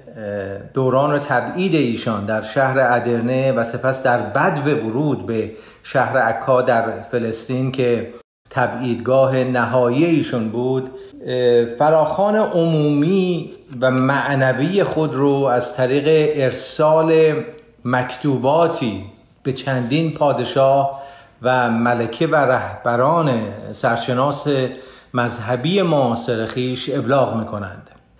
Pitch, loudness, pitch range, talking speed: 130 Hz, -18 LUFS, 120-145 Hz, 100 wpm